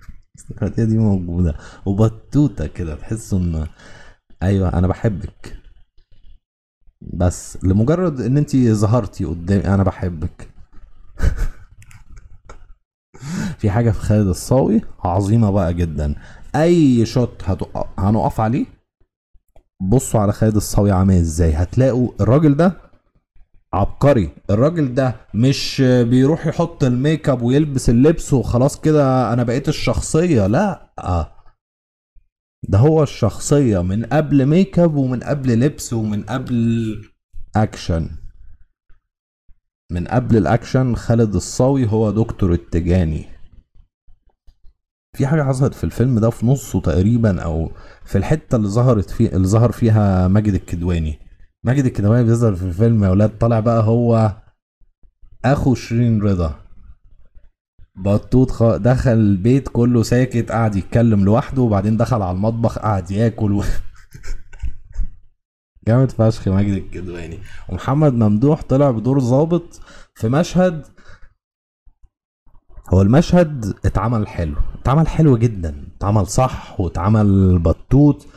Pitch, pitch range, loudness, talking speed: 105 Hz, 90-125 Hz, -17 LUFS, 115 wpm